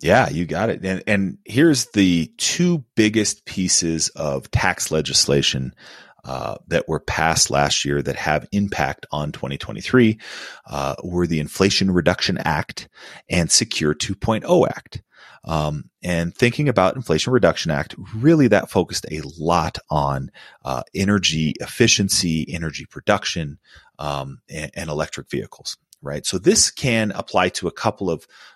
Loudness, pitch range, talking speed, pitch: -20 LUFS, 75-105 Hz, 140 wpm, 90 Hz